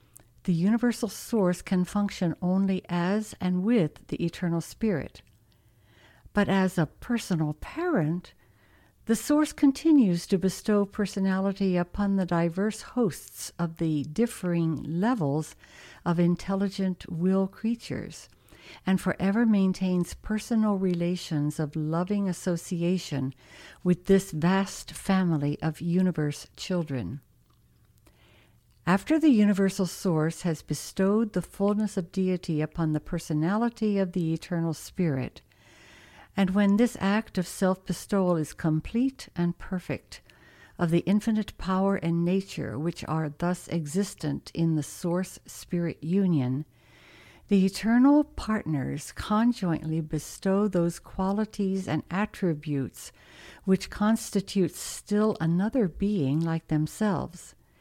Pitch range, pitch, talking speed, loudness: 160-200 Hz, 180 Hz, 115 wpm, -27 LUFS